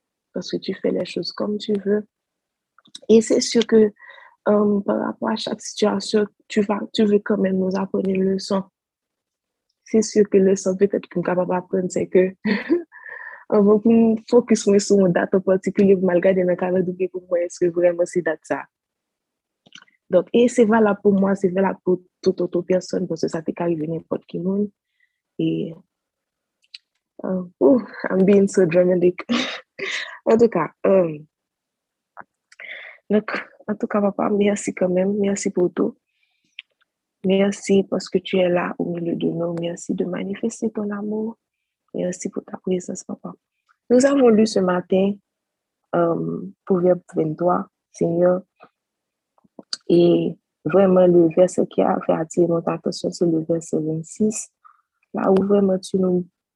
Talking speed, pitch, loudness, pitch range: 150 wpm, 195 Hz, -20 LUFS, 180-215 Hz